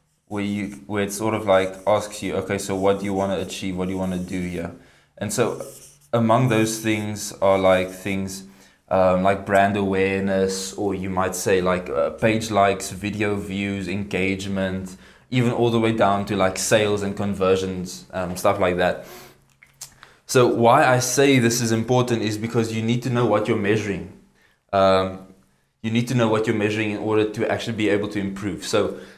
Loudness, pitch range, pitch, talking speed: -22 LUFS, 95-110 Hz, 100 Hz, 195 wpm